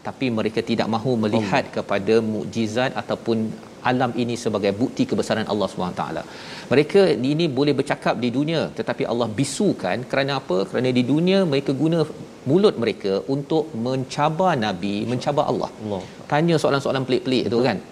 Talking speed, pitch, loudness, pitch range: 145 wpm, 130 Hz, -22 LUFS, 115-145 Hz